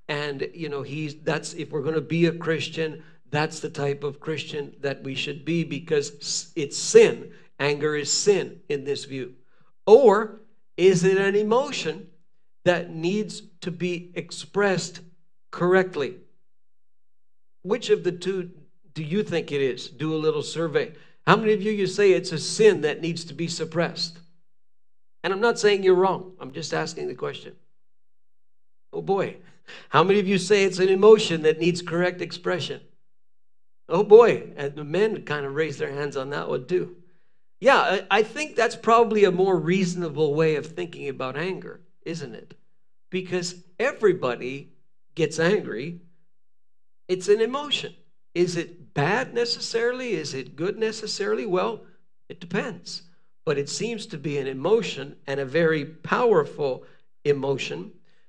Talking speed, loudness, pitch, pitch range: 155 wpm, -24 LUFS, 175 Hz, 155-205 Hz